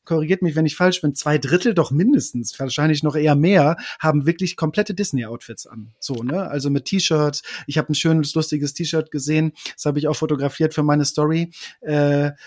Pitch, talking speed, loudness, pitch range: 155 Hz, 190 wpm, -20 LUFS, 145-165 Hz